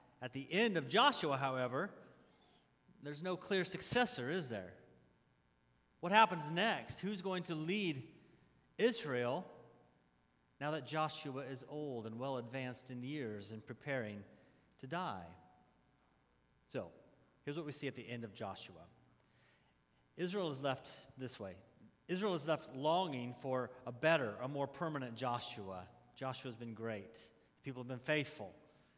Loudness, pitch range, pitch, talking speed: -40 LUFS, 120-160 Hz, 135 Hz, 140 wpm